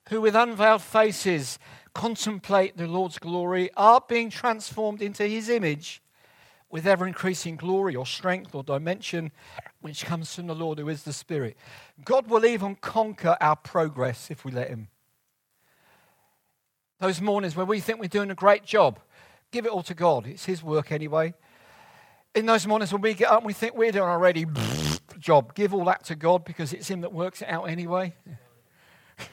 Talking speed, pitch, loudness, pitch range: 180 wpm, 180 Hz, -25 LUFS, 155-205 Hz